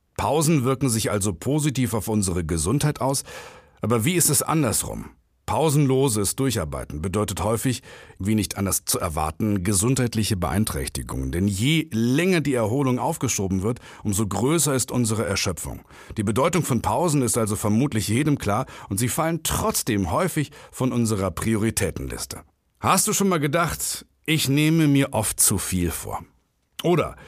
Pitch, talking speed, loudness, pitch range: 115 Hz, 145 wpm, -23 LUFS, 100-140 Hz